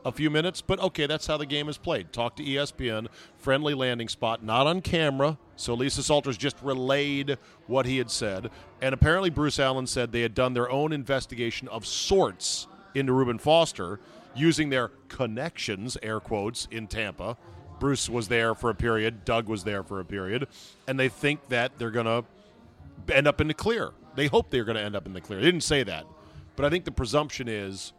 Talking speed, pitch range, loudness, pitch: 205 wpm, 115-145 Hz, -27 LUFS, 130 Hz